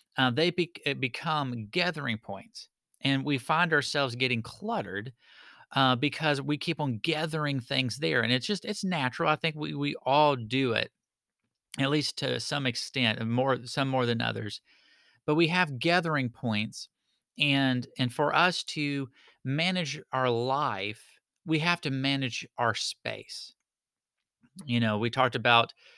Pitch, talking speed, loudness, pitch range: 135 Hz, 150 wpm, -28 LUFS, 125-155 Hz